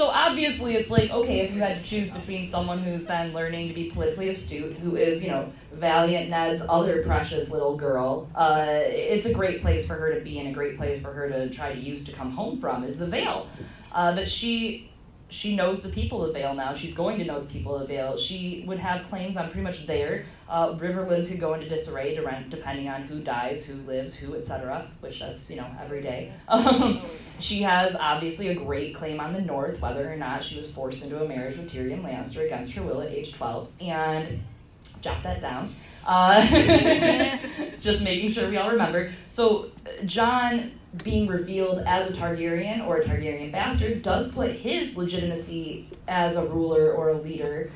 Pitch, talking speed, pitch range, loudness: 170 Hz, 205 wpm, 150-190 Hz, -26 LUFS